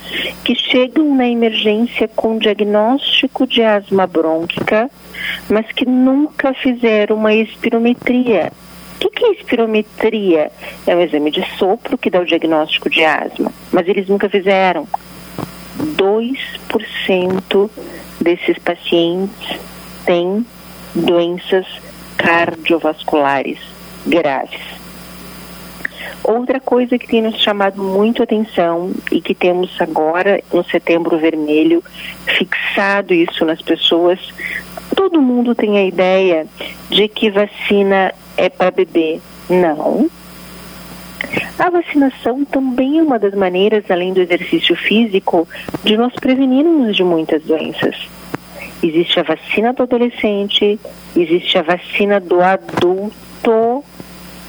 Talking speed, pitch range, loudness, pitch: 110 wpm, 175-240 Hz, -15 LUFS, 200 Hz